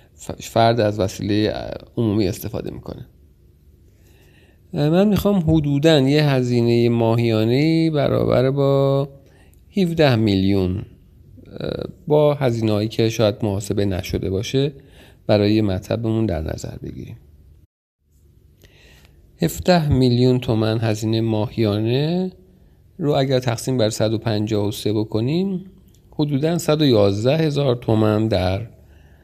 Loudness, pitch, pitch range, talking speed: -19 LUFS, 110 Hz, 95-135 Hz, 90 wpm